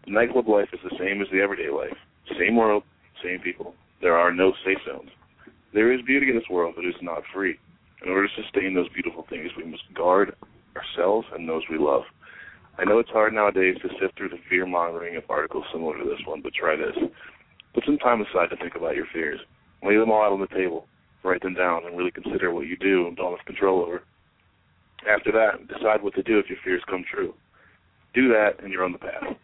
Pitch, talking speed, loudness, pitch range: 95 Hz, 225 wpm, -24 LUFS, 90-105 Hz